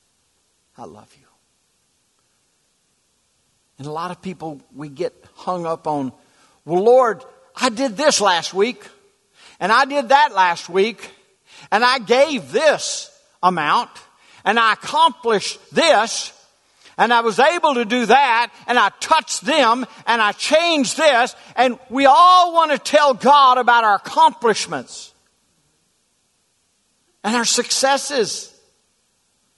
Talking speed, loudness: 130 wpm, -16 LUFS